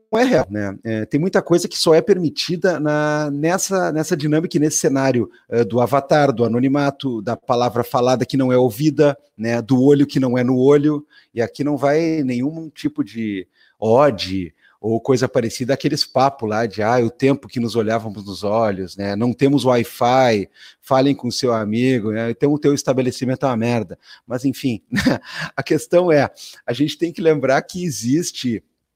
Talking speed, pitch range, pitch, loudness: 190 wpm, 120-150 Hz, 135 Hz, -18 LUFS